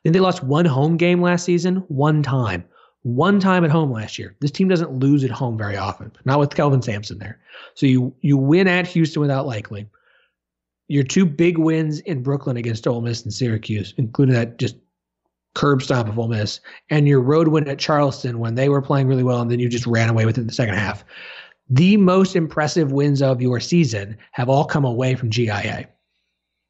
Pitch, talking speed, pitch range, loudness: 135 Hz, 205 wpm, 115-155 Hz, -19 LUFS